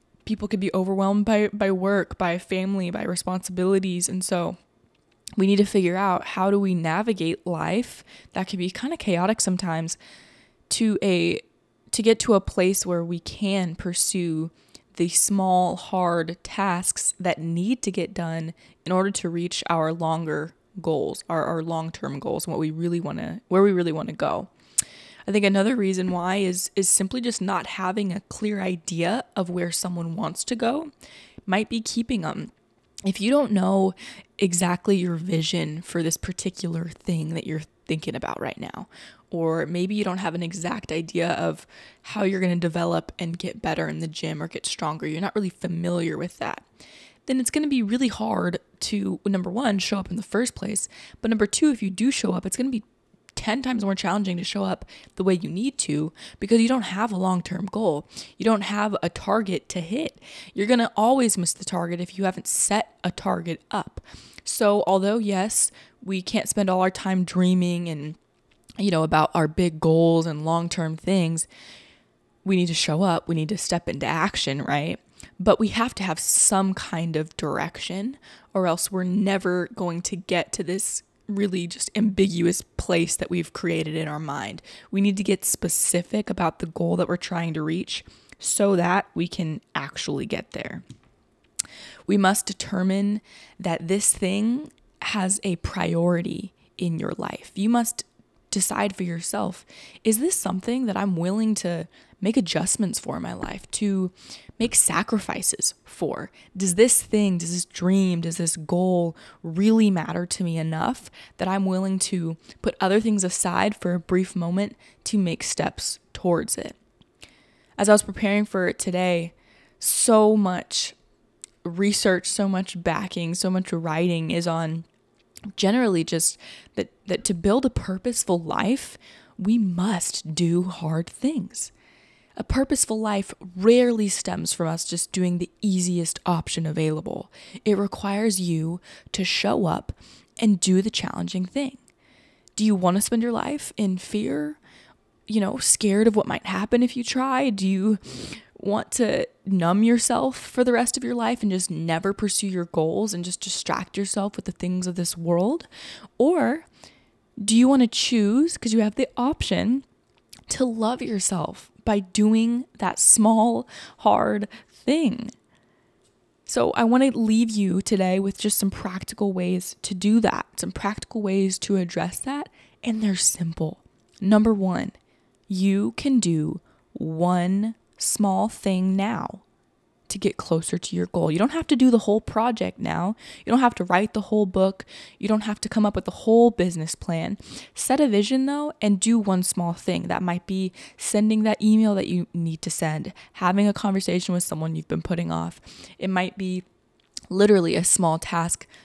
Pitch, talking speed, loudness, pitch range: 190 Hz, 175 wpm, -24 LUFS, 175-215 Hz